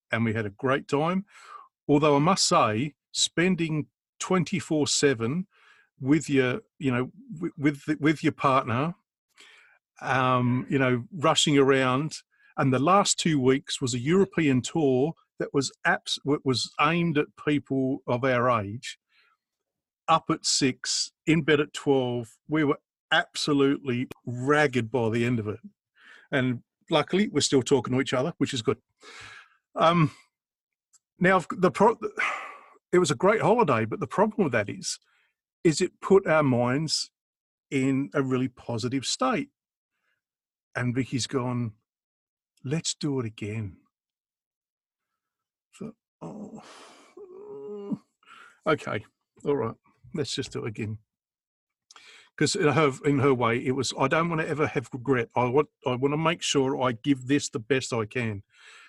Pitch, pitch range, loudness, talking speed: 140 Hz, 125-160 Hz, -26 LUFS, 145 wpm